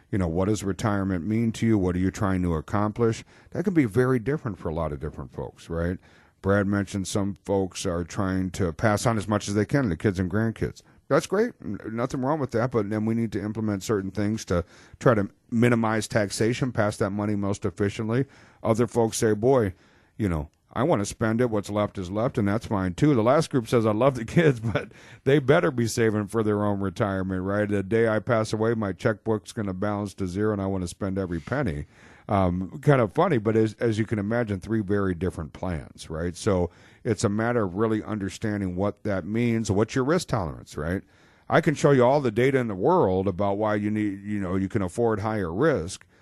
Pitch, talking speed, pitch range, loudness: 105 Hz, 225 wpm, 95-115 Hz, -25 LUFS